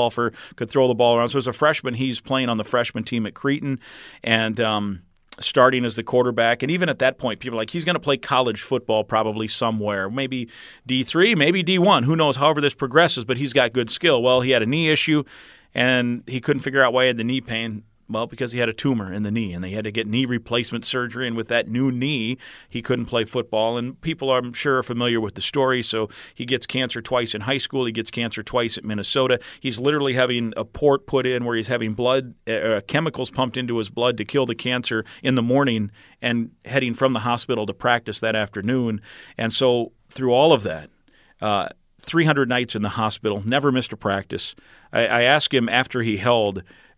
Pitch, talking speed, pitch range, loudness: 120 Hz, 225 wpm, 115-130 Hz, -21 LUFS